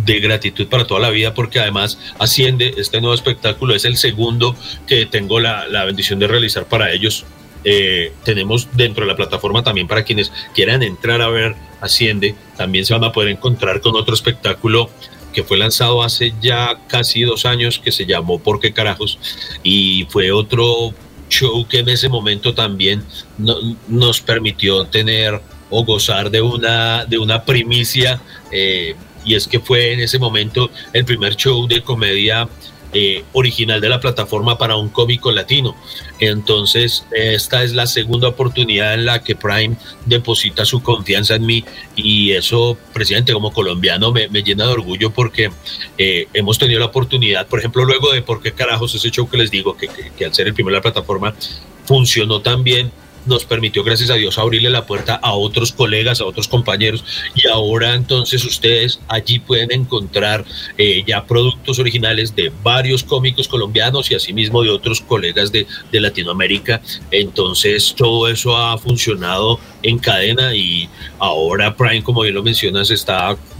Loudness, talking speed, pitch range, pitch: -14 LUFS, 170 wpm, 105-120 Hz, 115 Hz